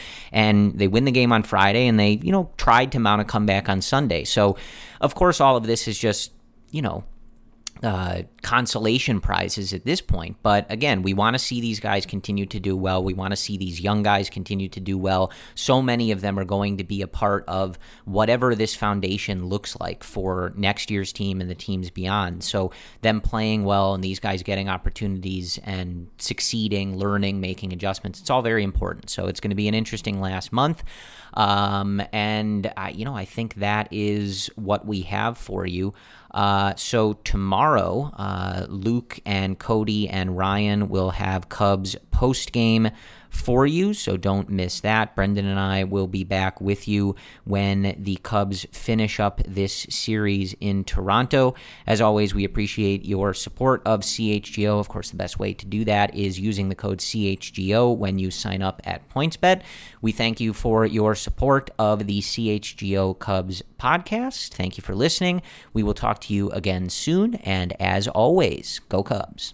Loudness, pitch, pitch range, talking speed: -23 LUFS, 100 Hz, 95-110 Hz, 185 wpm